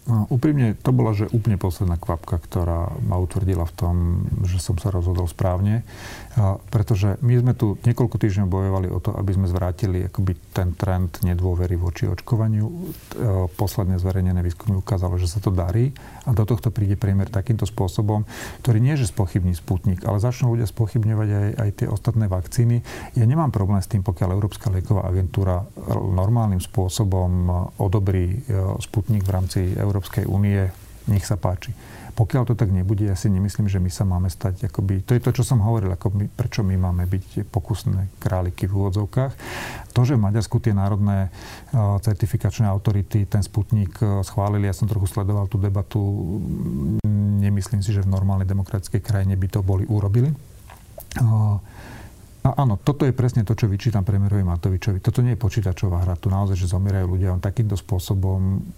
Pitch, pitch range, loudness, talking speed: 100 Hz, 95-115 Hz, -22 LUFS, 170 wpm